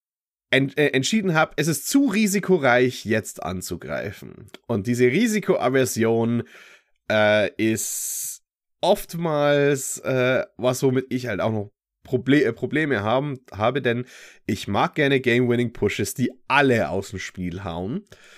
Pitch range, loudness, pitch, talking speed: 110-145 Hz, -22 LUFS, 125 Hz, 125 wpm